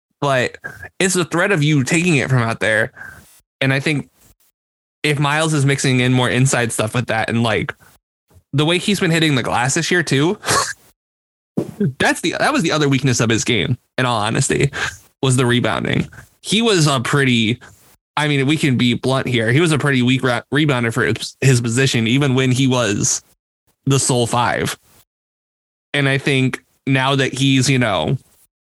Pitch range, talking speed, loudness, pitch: 120-145 Hz, 185 wpm, -17 LUFS, 130 Hz